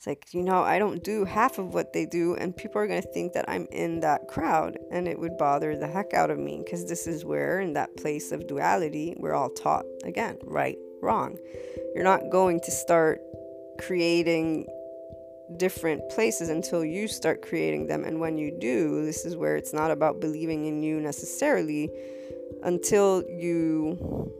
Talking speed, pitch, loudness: 185 wpm, 160 Hz, -28 LUFS